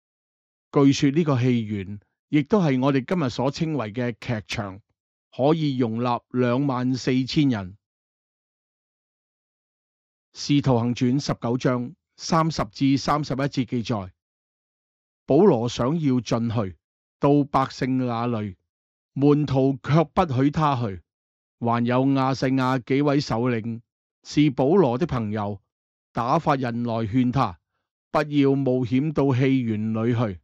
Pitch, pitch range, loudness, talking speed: 130 Hz, 115-140 Hz, -23 LUFS, 180 characters per minute